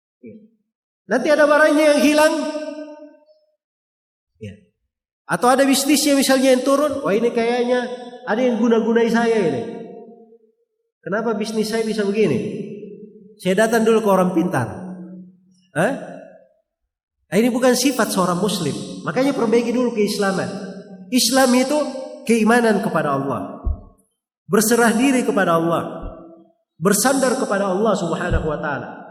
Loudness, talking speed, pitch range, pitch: -18 LUFS, 120 wpm, 205-265 Hz, 230 Hz